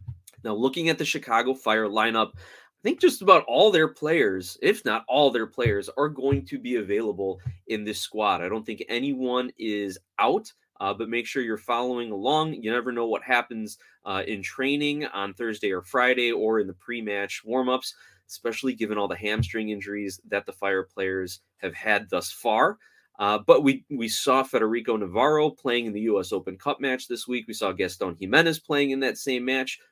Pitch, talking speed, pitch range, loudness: 120 Hz, 195 wpm, 105-140 Hz, -25 LUFS